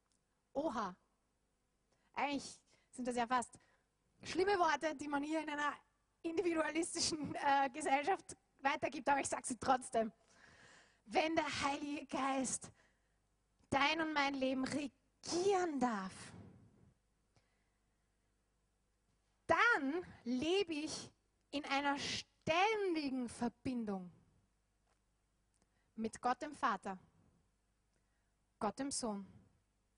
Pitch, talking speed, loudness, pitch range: 270 Hz, 90 wpm, -38 LUFS, 210-305 Hz